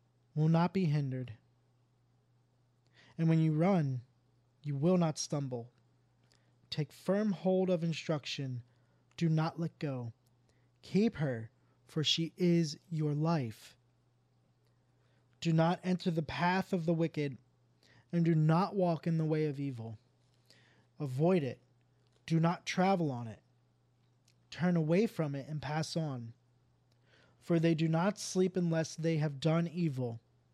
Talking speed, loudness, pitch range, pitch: 135 wpm, -33 LUFS, 125-165 Hz, 145 Hz